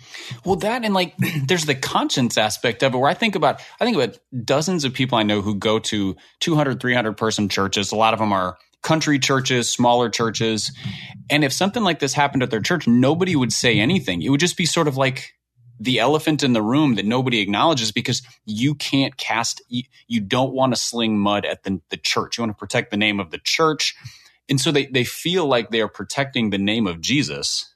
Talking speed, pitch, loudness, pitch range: 220 wpm, 130 Hz, -20 LUFS, 110-150 Hz